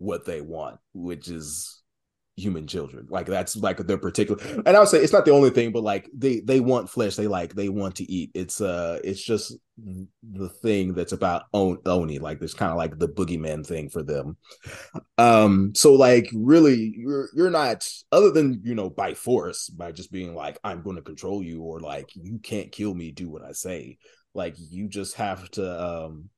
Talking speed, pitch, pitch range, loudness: 200 wpm, 100 Hz, 90-115 Hz, -22 LUFS